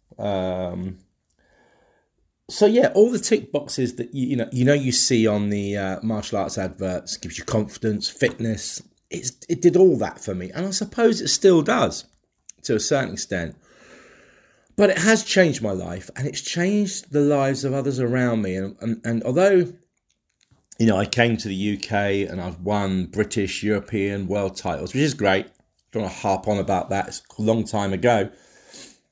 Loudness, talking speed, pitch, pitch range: -22 LUFS, 190 wpm, 110 Hz, 100-145 Hz